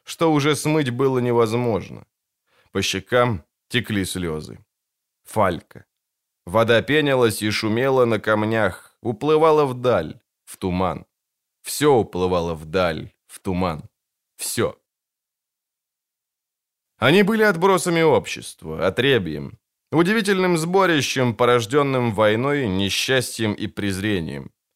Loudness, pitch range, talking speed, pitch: -20 LUFS, 100-145 Hz, 90 wpm, 120 Hz